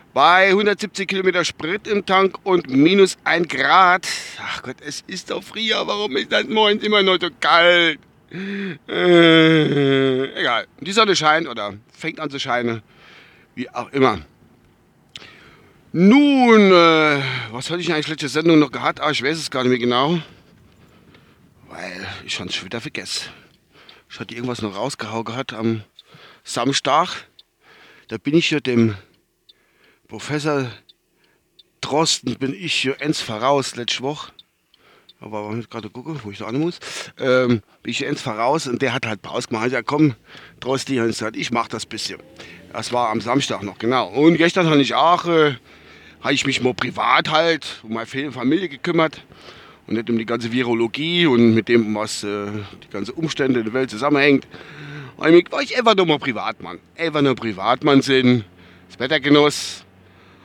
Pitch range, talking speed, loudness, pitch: 115-165 Hz, 165 wpm, -18 LUFS, 140 Hz